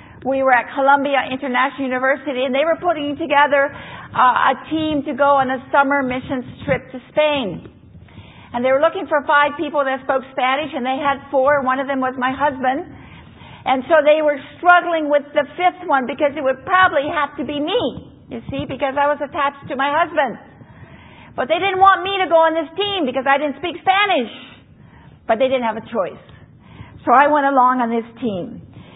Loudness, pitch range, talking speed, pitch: -18 LUFS, 265-305 Hz, 200 wpm, 280 Hz